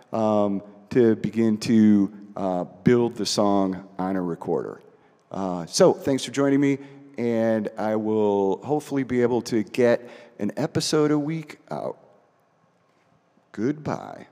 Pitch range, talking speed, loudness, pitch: 100-130 Hz, 130 wpm, -23 LUFS, 110 Hz